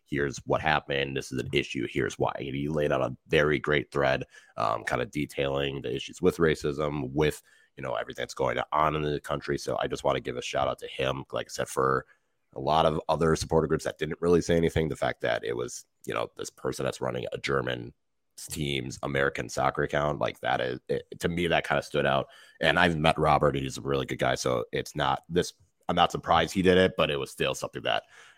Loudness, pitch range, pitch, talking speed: -28 LUFS, 70-80 Hz, 75 Hz, 245 wpm